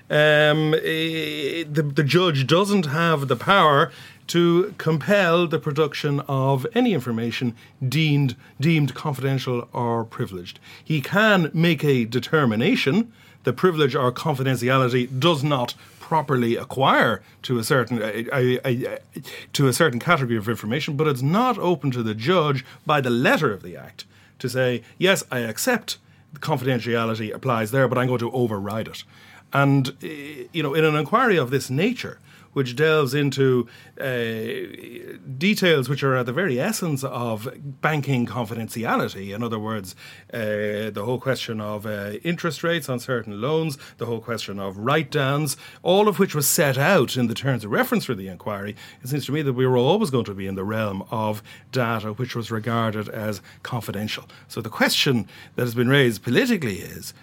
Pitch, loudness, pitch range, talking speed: 130 Hz, -22 LUFS, 120-155 Hz, 165 wpm